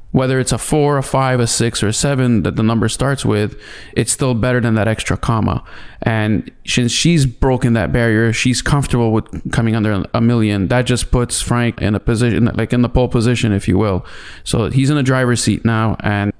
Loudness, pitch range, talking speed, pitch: -16 LUFS, 110-125 Hz, 215 wpm, 120 Hz